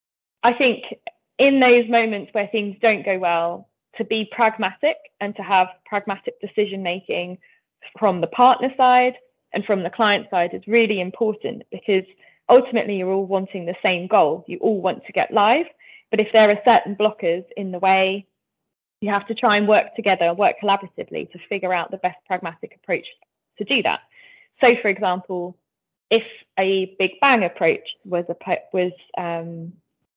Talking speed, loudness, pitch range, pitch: 165 wpm, -20 LUFS, 185-230 Hz, 205 Hz